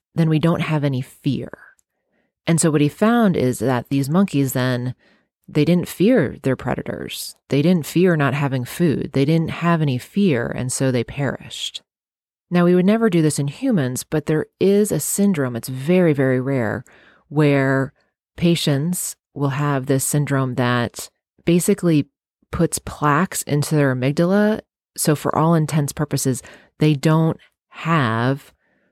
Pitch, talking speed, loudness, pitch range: 145 Hz, 155 wpm, -19 LUFS, 135-170 Hz